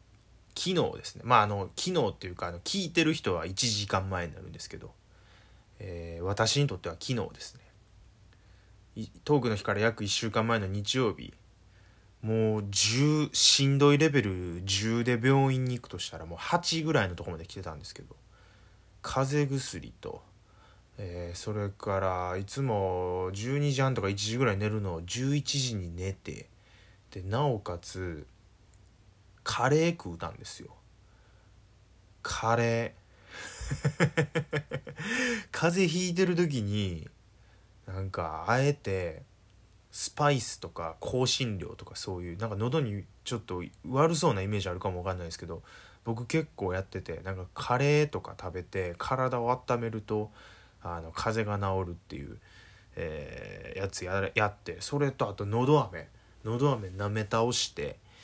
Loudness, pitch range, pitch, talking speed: -30 LUFS, 95-125 Hz, 105 Hz, 275 characters per minute